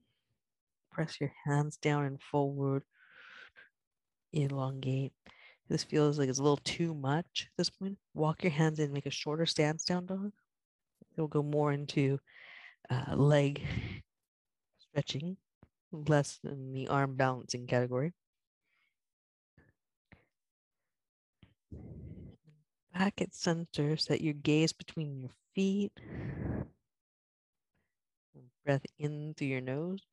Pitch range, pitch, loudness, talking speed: 135-165 Hz, 150 Hz, -34 LUFS, 115 wpm